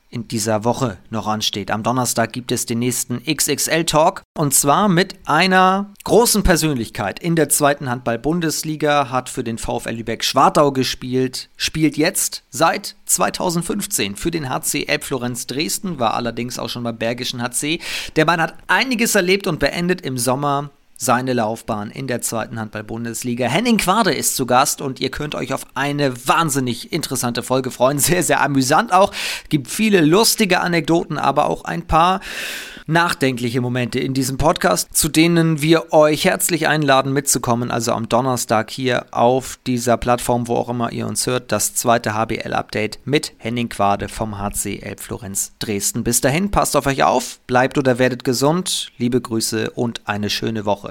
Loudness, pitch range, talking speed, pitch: -18 LUFS, 115-155 Hz, 160 wpm, 130 Hz